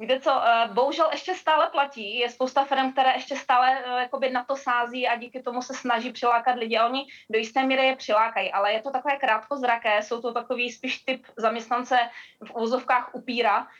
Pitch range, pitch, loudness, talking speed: 235-265 Hz, 250 Hz, -25 LUFS, 190 wpm